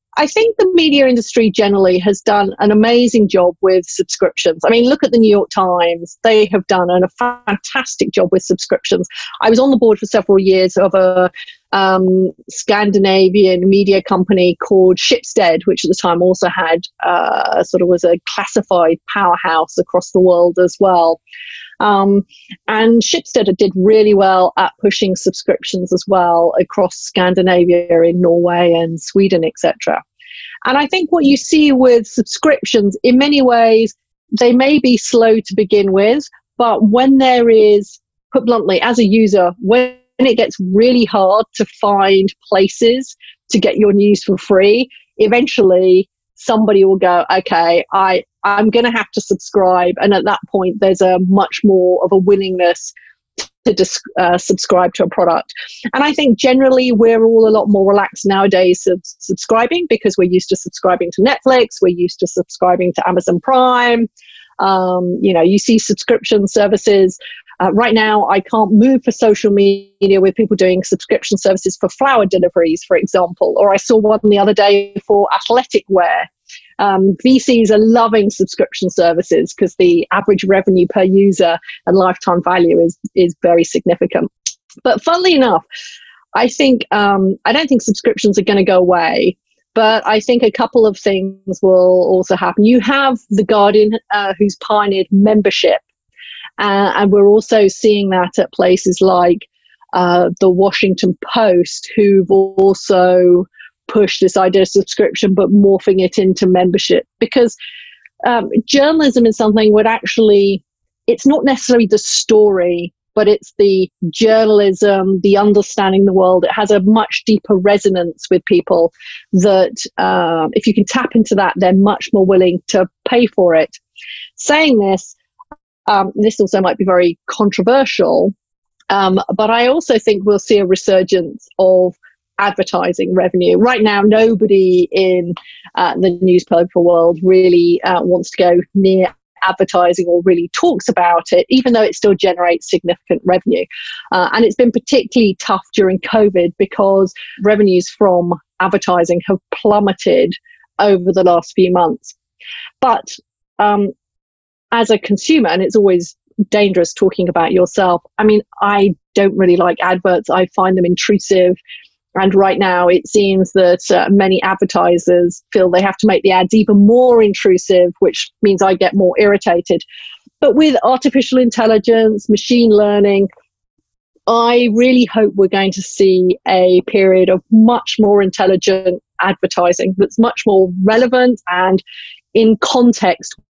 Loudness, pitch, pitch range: -12 LUFS, 200 Hz, 185-225 Hz